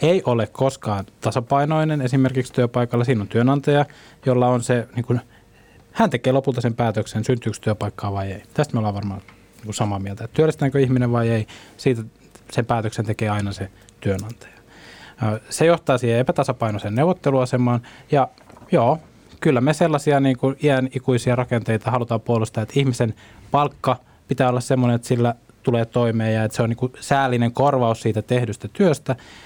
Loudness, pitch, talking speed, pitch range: -21 LUFS, 120 Hz, 160 wpm, 110-135 Hz